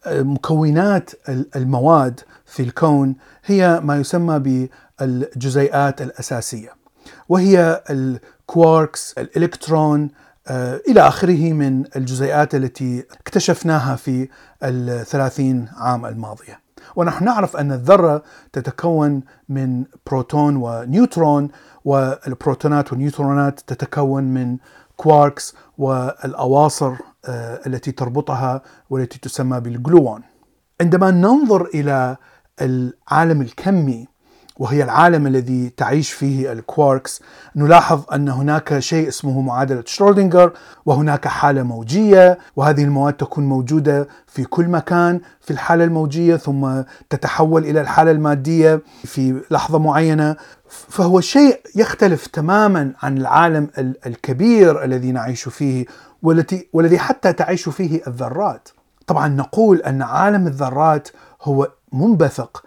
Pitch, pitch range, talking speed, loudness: 145 Hz, 130-165 Hz, 100 wpm, -16 LUFS